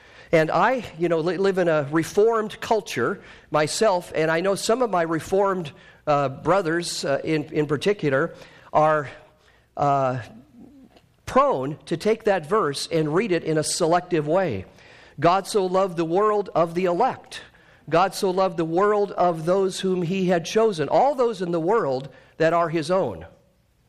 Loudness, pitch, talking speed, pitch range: -22 LUFS, 175 Hz, 165 wpm, 155-195 Hz